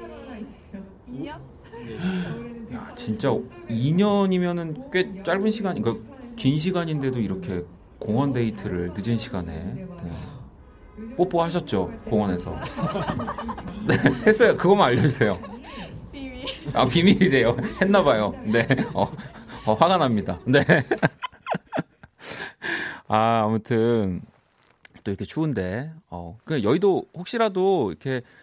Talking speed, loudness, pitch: 215 characters per minute, -23 LUFS, 135 Hz